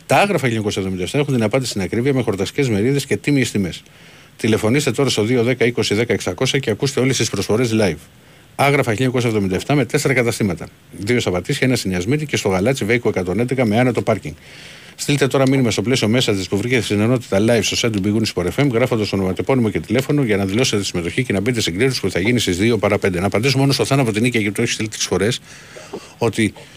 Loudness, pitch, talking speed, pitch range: -18 LUFS, 115 Hz, 210 wpm, 100-130 Hz